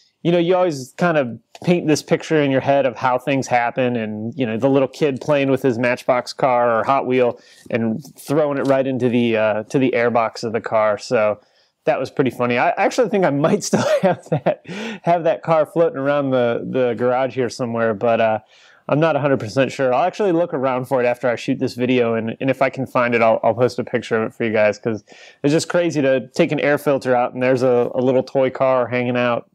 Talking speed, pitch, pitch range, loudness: 240 wpm, 130 Hz, 120-145 Hz, -19 LUFS